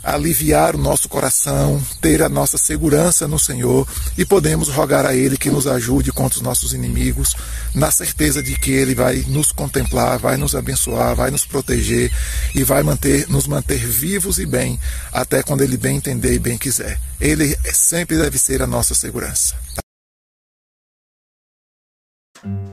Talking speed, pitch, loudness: 155 wpm, 130 Hz, -16 LUFS